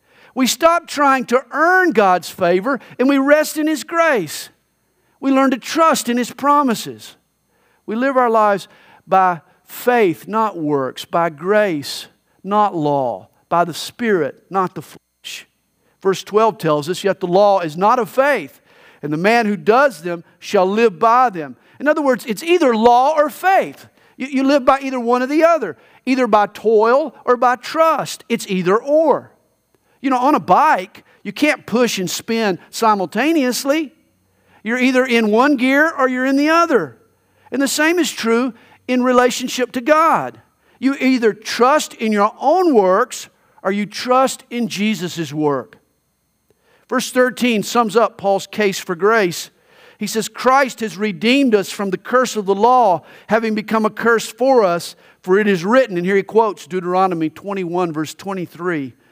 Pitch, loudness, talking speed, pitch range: 230 Hz, -16 LUFS, 165 wpm, 190-265 Hz